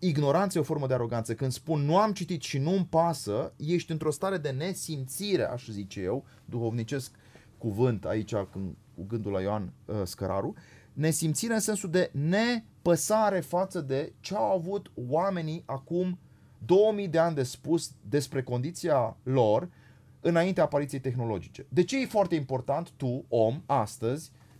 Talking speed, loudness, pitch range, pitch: 150 wpm, -29 LUFS, 125-175 Hz, 145 Hz